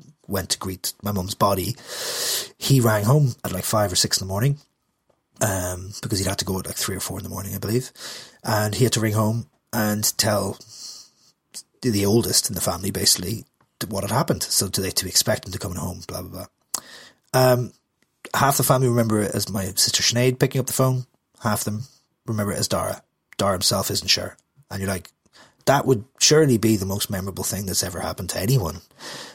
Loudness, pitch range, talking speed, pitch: -22 LUFS, 95-125 Hz, 210 wpm, 105 Hz